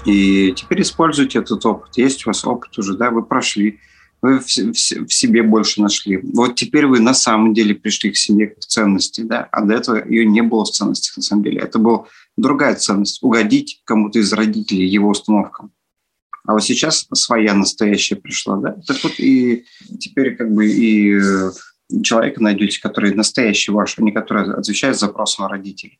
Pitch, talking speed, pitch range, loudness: 110 Hz, 175 wpm, 105-125 Hz, -15 LUFS